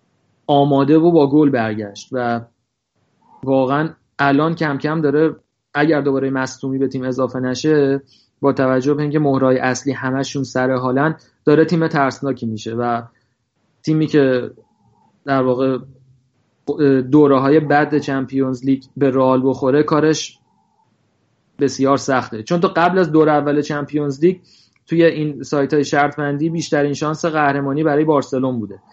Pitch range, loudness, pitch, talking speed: 130-150 Hz, -17 LUFS, 140 Hz, 135 wpm